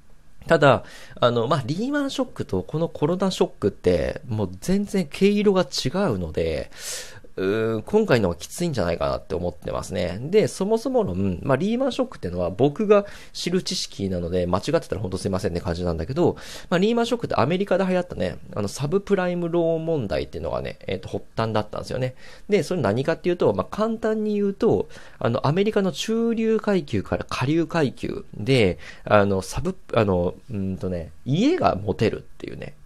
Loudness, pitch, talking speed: -23 LUFS, 165 Hz, 415 characters per minute